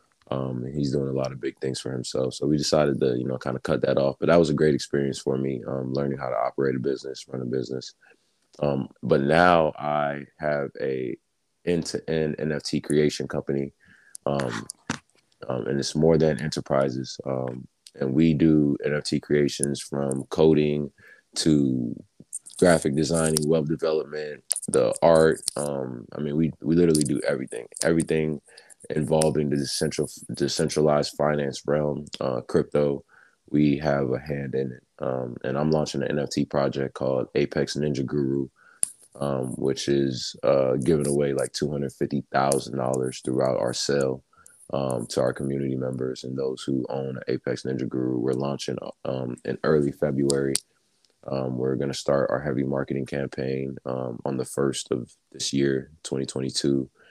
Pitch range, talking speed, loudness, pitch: 65-75 Hz, 160 wpm, -25 LUFS, 70 Hz